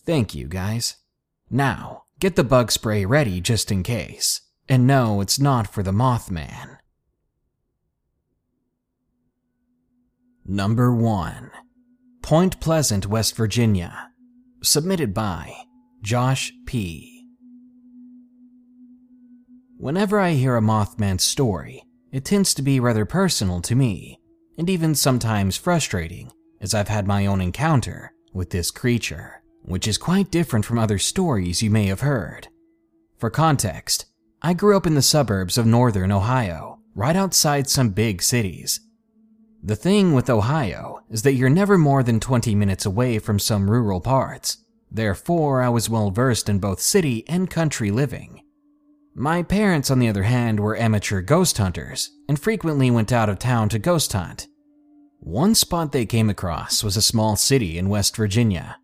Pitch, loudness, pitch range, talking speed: 125 Hz, -20 LUFS, 105-170 Hz, 145 wpm